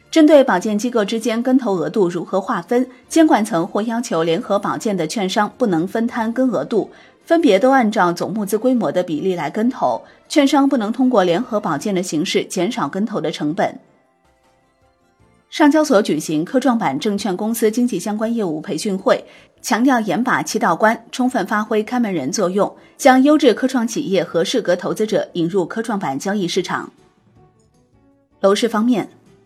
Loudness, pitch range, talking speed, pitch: -18 LUFS, 185-250 Hz, 275 characters per minute, 220 Hz